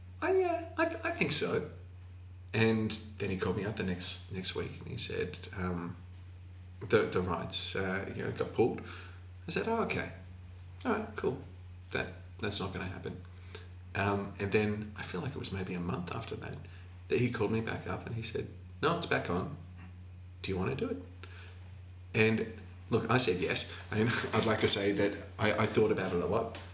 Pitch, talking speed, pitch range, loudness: 90 Hz, 205 wpm, 90-105 Hz, -33 LUFS